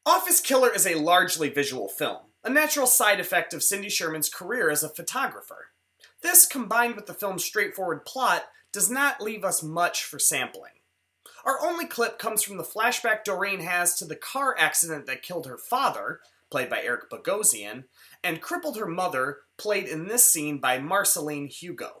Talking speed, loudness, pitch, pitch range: 175 wpm, -24 LUFS, 195 Hz, 160-235 Hz